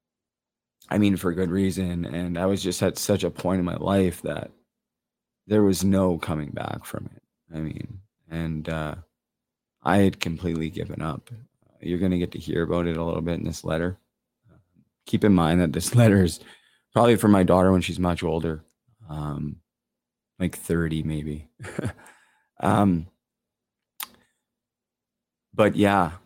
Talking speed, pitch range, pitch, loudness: 160 wpm, 80-95 Hz, 90 Hz, -24 LUFS